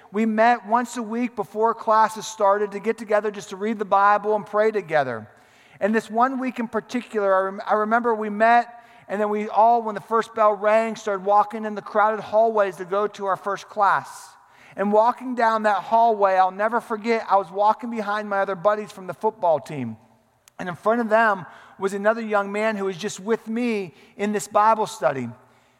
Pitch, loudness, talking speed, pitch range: 210 Hz, -22 LUFS, 205 wpm, 195-225 Hz